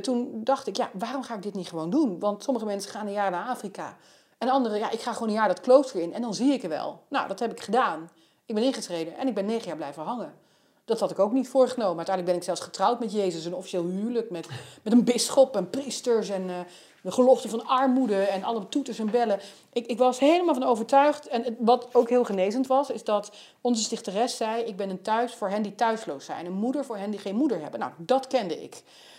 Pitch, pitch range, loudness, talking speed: 230 Hz, 200-255 Hz, -26 LUFS, 250 wpm